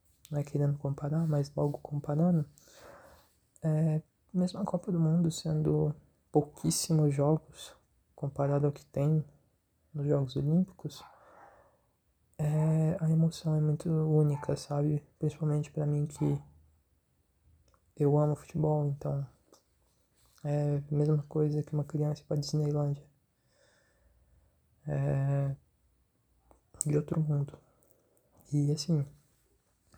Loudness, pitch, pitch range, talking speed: -31 LUFS, 145 Hz, 140-155 Hz, 105 wpm